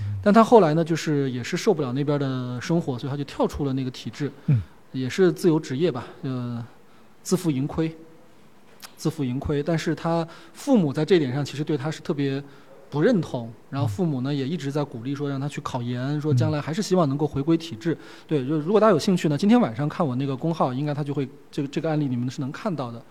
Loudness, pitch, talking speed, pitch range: -24 LUFS, 150 Hz, 340 characters per minute, 135-165 Hz